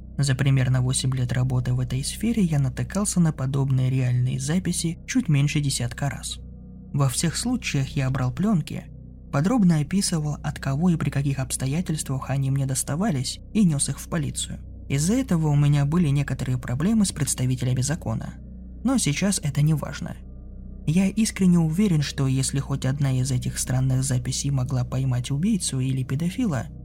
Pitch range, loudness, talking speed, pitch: 130-165 Hz, -24 LUFS, 160 wpm, 140 Hz